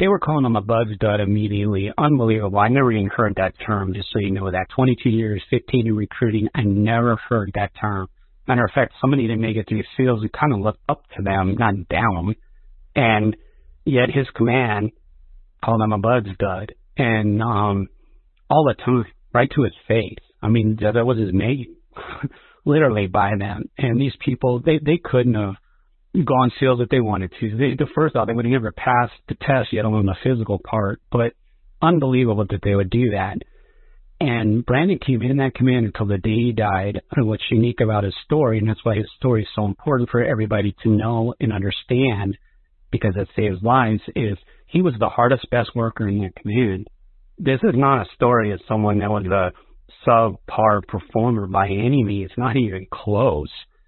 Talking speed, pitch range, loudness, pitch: 195 wpm, 105-125 Hz, -20 LUFS, 110 Hz